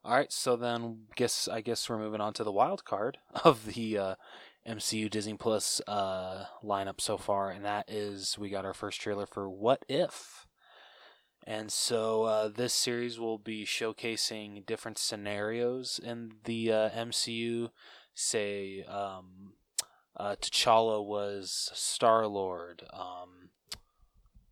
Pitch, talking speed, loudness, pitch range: 110 Hz, 140 wpm, -32 LUFS, 100-115 Hz